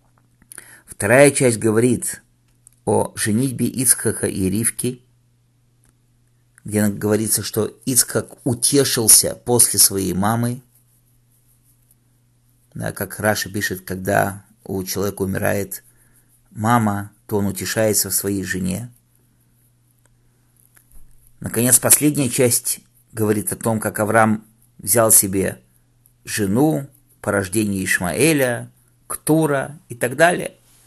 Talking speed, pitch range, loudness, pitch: 95 wpm, 105-120 Hz, -18 LUFS, 120 Hz